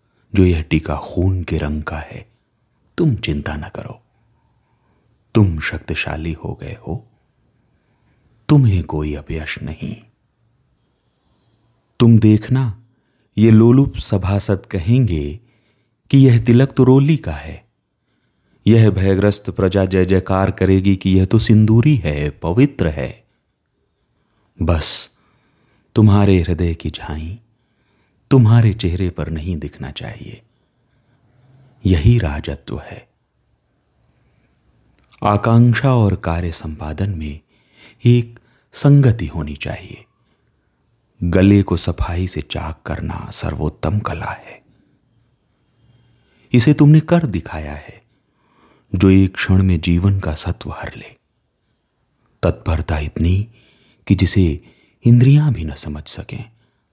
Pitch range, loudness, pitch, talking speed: 85-120 Hz, -16 LUFS, 100 Hz, 110 wpm